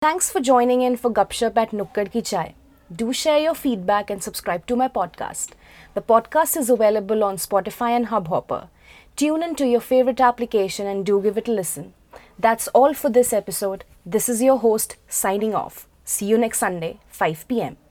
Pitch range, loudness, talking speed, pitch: 200-250 Hz, -21 LUFS, 190 wpm, 225 Hz